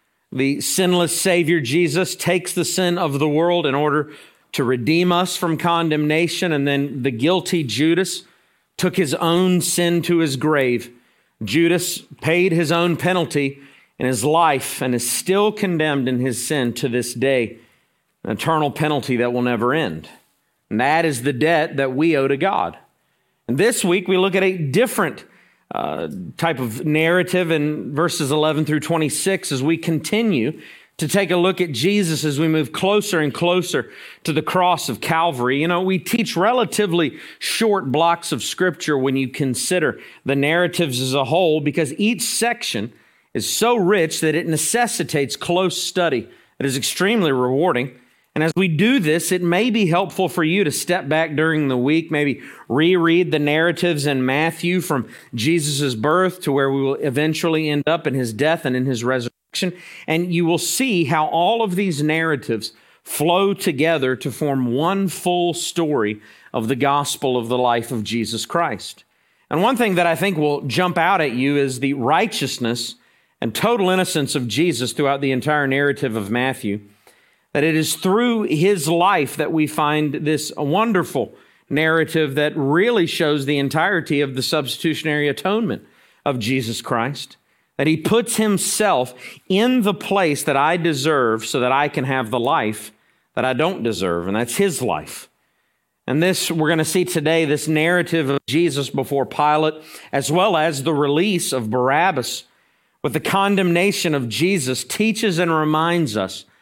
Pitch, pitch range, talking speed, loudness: 155 Hz, 140-175 Hz, 170 wpm, -19 LUFS